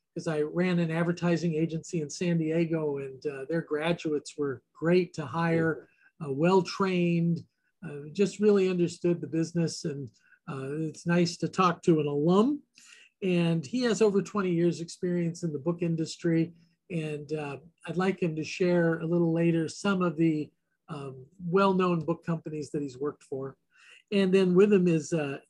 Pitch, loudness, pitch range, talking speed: 170 Hz, -28 LUFS, 155-180 Hz, 175 wpm